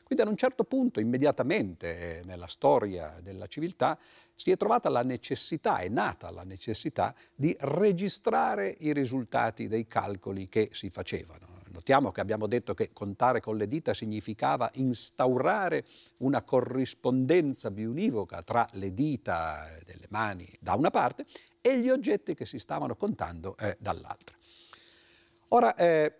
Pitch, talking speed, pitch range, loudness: 115 Hz, 140 wpm, 95-140 Hz, -30 LUFS